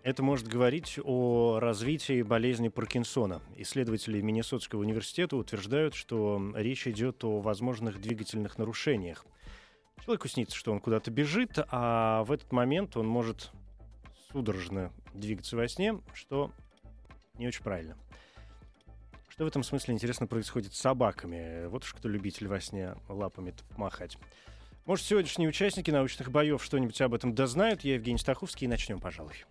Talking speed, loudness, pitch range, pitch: 140 wpm, -32 LUFS, 105-135 Hz, 120 Hz